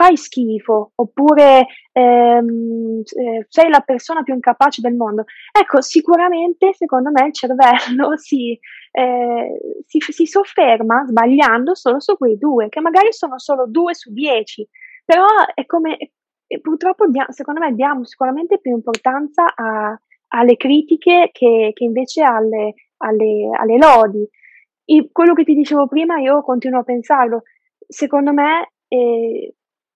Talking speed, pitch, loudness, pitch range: 135 wpm, 270 Hz, -14 LUFS, 235-330 Hz